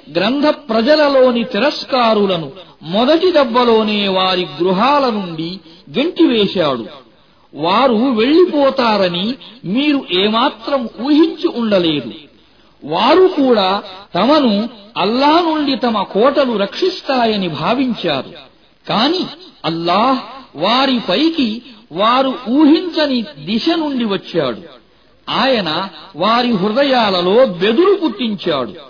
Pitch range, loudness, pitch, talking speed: 200-285 Hz, -14 LUFS, 235 Hz, 80 wpm